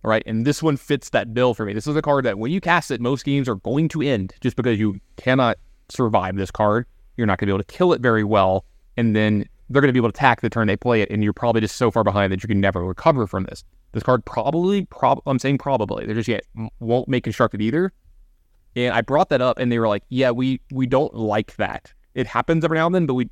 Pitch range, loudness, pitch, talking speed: 105-135 Hz, -21 LUFS, 115 Hz, 275 wpm